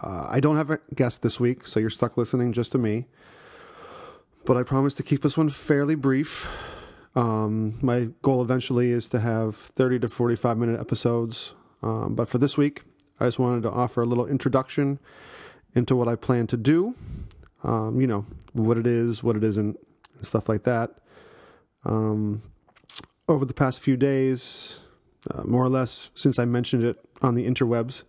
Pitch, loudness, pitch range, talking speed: 125 Hz, -25 LUFS, 115-135 Hz, 180 wpm